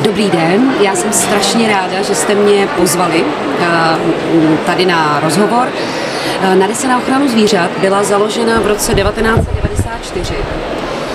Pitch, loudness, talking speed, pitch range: 200 Hz, -12 LUFS, 120 wpm, 180-215 Hz